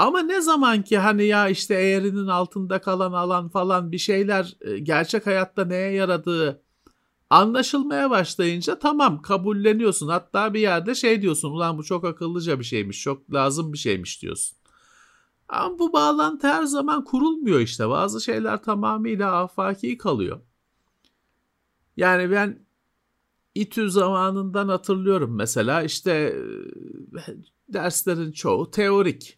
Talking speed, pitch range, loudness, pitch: 125 wpm, 165-215 Hz, -22 LUFS, 190 Hz